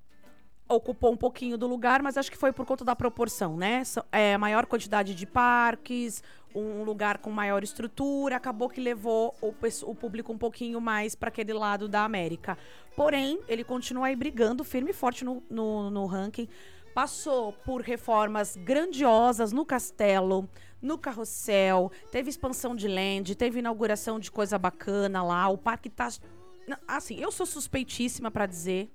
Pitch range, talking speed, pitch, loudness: 205-250 Hz, 160 wpm, 230 Hz, -29 LUFS